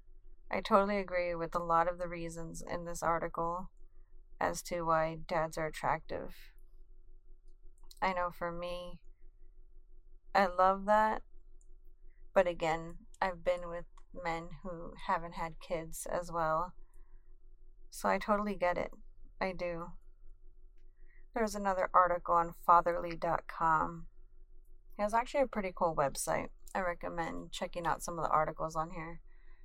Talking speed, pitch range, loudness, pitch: 135 wpm, 165-185 Hz, -34 LUFS, 175 Hz